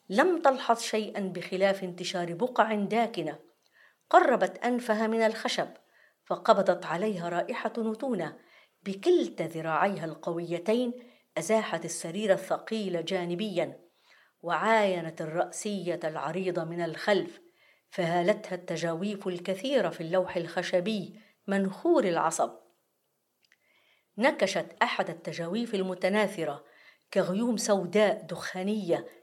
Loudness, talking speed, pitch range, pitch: -29 LUFS, 85 wpm, 175-220 Hz, 190 Hz